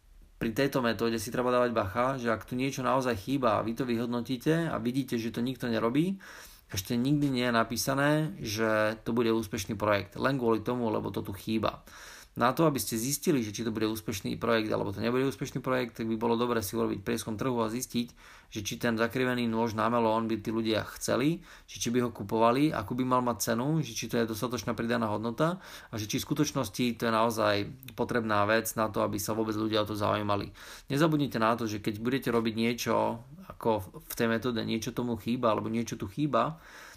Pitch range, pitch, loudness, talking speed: 110-125 Hz, 115 Hz, -30 LUFS, 215 wpm